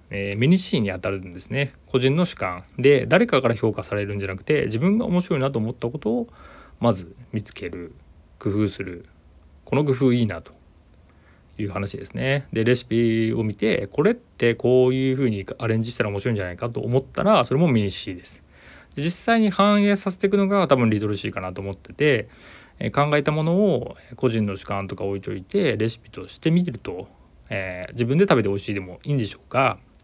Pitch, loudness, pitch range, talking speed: 115 Hz, -22 LUFS, 100-140 Hz, 395 characters per minute